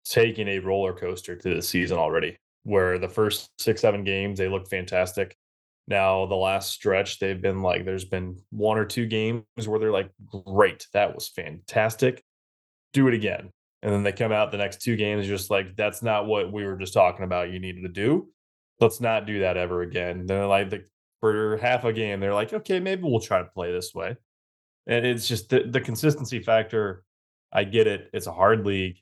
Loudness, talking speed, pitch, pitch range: -25 LUFS, 210 wpm, 100 Hz, 95-110 Hz